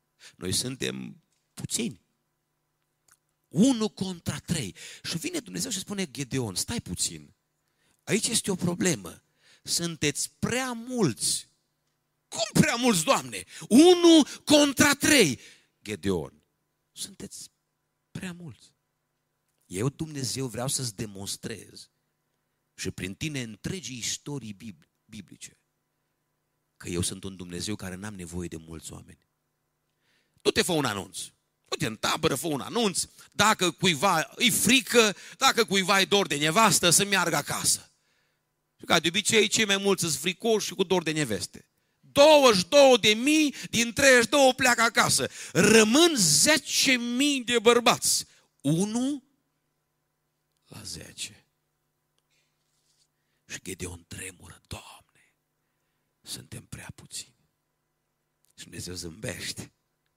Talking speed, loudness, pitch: 120 wpm, -24 LUFS, 185 Hz